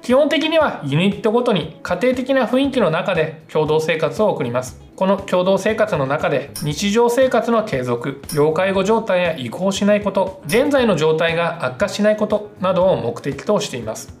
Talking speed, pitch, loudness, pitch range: 355 characters per minute, 195 Hz, -18 LUFS, 155-225 Hz